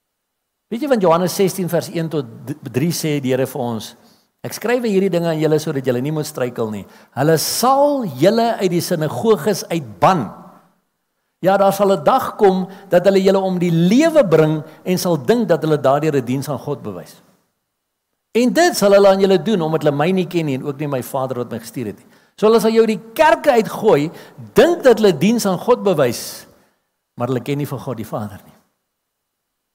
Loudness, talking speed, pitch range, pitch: -16 LUFS, 210 wpm, 145-200 Hz, 175 Hz